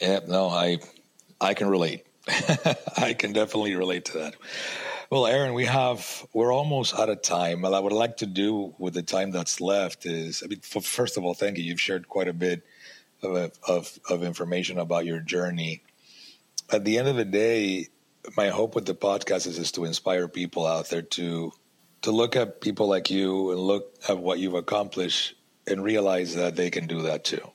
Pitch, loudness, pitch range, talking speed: 90 Hz, -26 LUFS, 85-105 Hz, 200 wpm